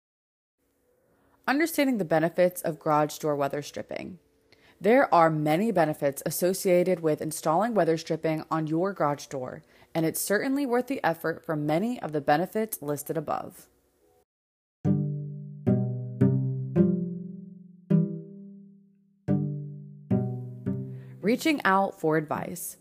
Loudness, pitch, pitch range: -27 LUFS, 160 Hz, 145-185 Hz